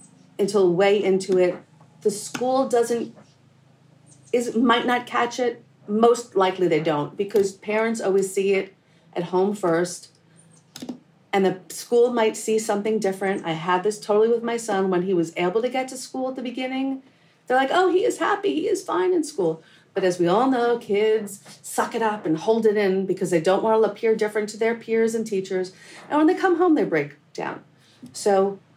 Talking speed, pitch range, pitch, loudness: 195 wpm, 180-235 Hz, 210 Hz, -22 LUFS